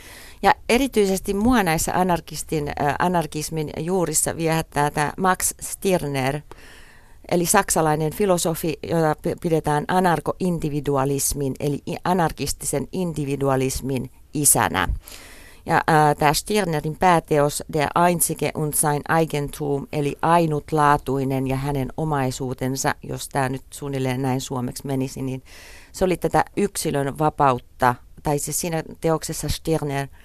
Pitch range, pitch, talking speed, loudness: 140-165 Hz, 150 Hz, 110 wpm, -22 LUFS